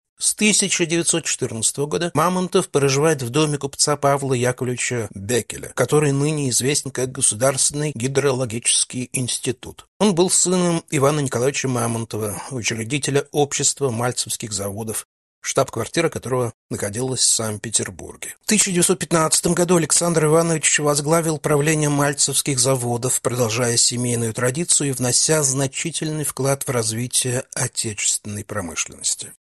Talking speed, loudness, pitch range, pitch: 110 wpm, -19 LUFS, 120-155 Hz, 135 Hz